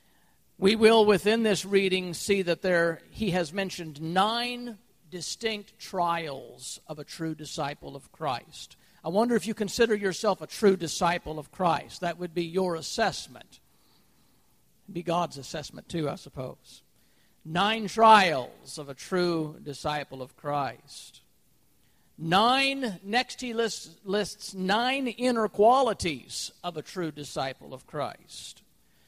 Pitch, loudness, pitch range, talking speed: 180 Hz, -27 LUFS, 160-215 Hz, 135 wpm